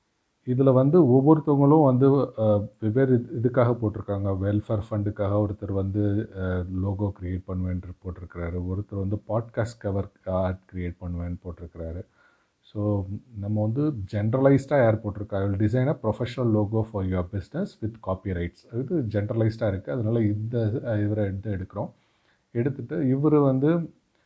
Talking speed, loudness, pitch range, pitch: 125 wpm, -25 LUFS, 95-125 Hz, 105 Hz